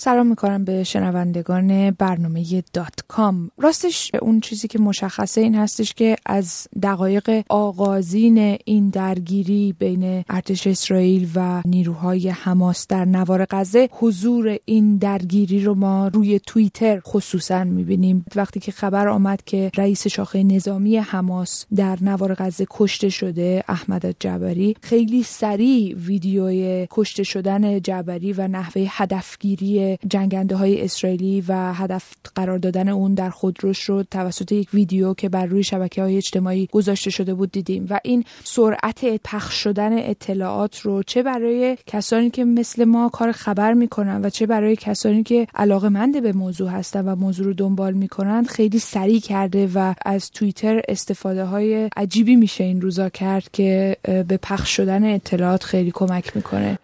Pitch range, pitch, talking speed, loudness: 190-210 Hz, 195 Hz, 145 wpm, -20 LUFS